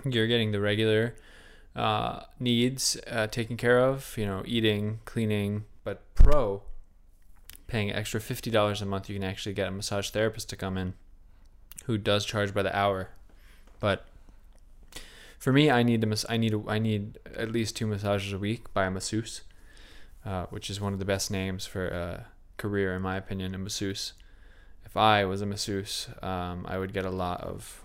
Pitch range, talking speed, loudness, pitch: 95-110 Hz, 185 wpm, -29 LUFS, 100 Hz